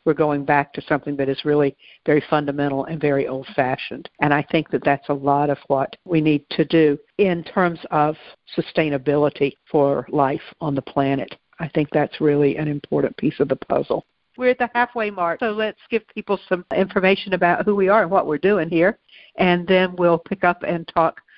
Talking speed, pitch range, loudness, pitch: 205 wpm, 145-185 Hz, -20 LUFS, 160 Hz